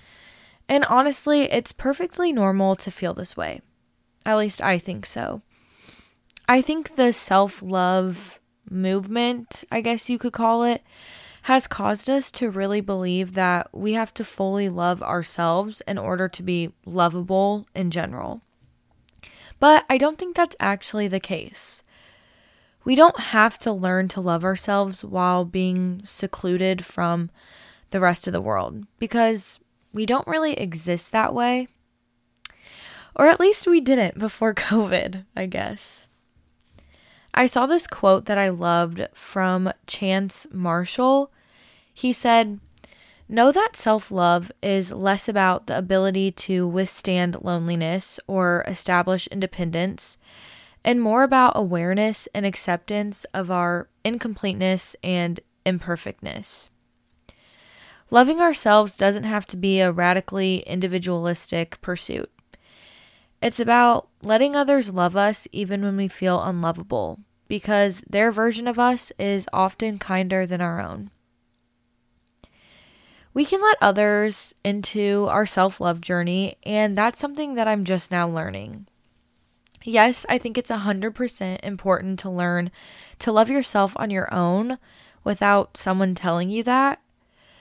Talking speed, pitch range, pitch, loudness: 130 wpm, 180-230 Hz, 195 Hz, -22 LUFS